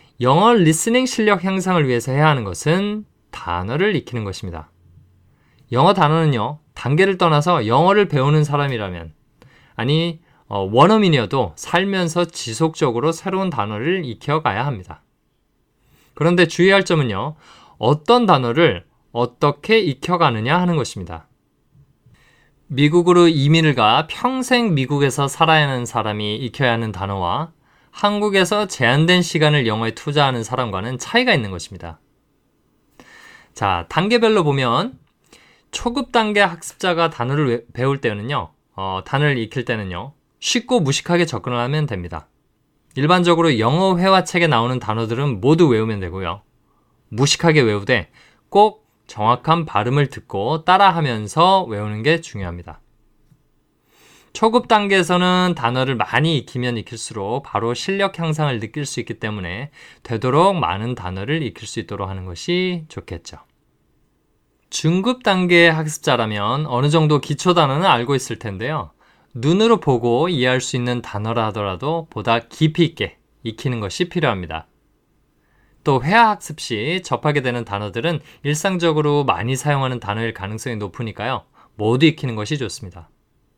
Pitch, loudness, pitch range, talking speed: 145 Hz, -18 LUFS, 115-170 Hz, 315 characters per minute